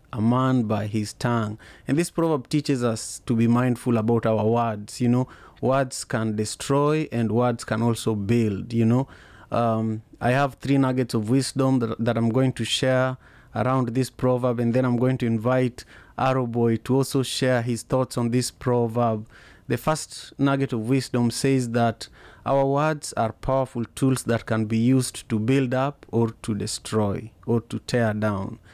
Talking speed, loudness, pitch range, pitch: 180 wpm, -24 LUFS, 115-130 Hz, 120 Hz